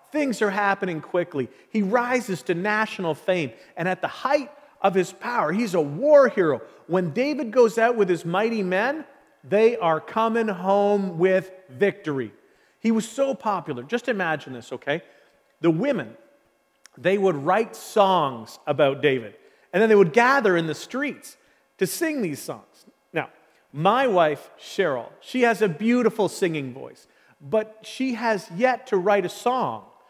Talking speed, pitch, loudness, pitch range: 160 wpm, 205 Hz, -23 LUFS, 175-240 Hz